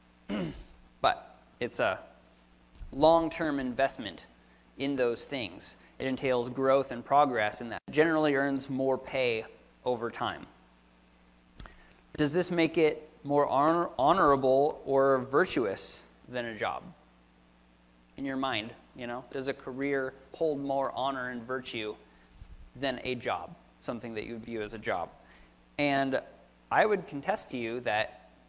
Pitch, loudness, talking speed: 125 Hz, -30 LUFS, 135 wpm